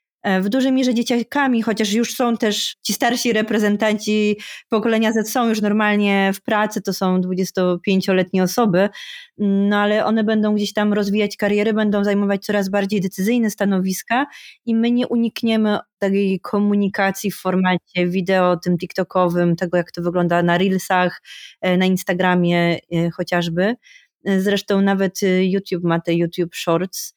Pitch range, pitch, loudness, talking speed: 185-220 Hz, 200 Hz, -19 LUFS, 140 wpm